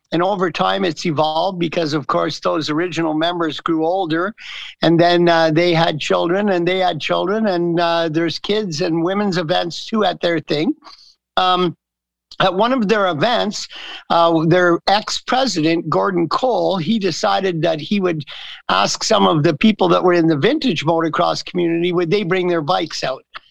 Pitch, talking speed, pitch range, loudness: 175 Hz, 175 wpm, 165-190 Hz, -17 LUFS